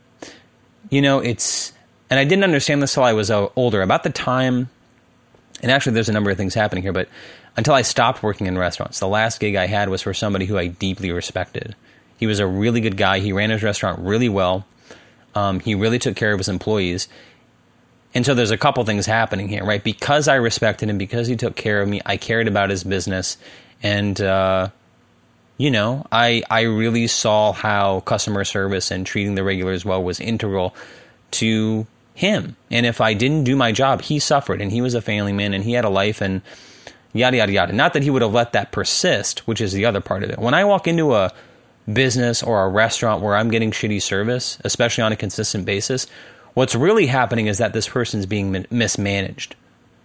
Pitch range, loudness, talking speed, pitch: 100-120 Hz, -19 LUFS, 210 wpm, 110 Hz